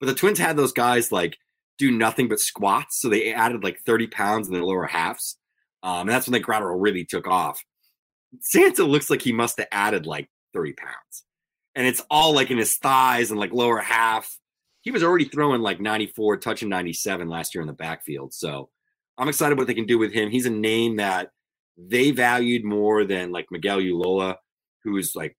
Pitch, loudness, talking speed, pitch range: 115 Hz, -22 LUFS, 205 wpm, 100-130 Hz